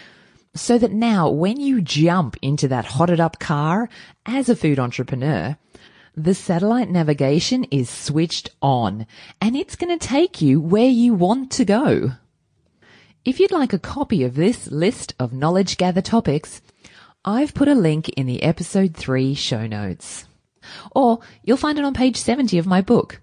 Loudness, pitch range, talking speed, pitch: -19 LUFS, 140-235 Hz, 165 wpm, 180 Hz